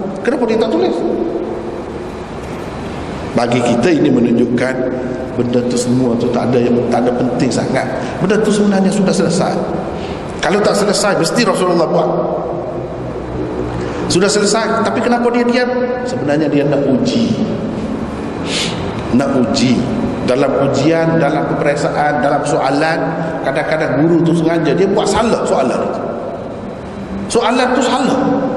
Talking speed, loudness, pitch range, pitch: 125 wpm, -15 LUFS, 125-210 Hz, 160 Hz